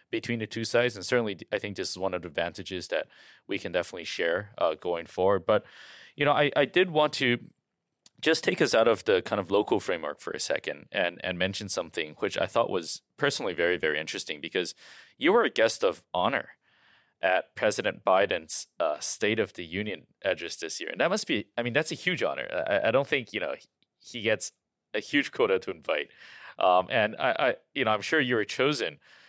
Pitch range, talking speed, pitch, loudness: 95-150 Hz, 220 wpm, 120 Hz, -28 LUFS